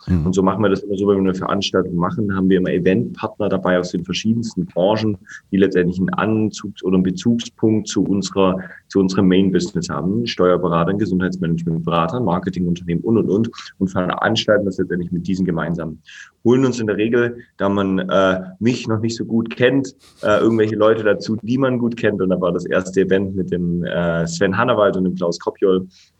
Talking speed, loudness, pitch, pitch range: 190 wpm, -18 LUFS, 95 Hz, 90-110 Hz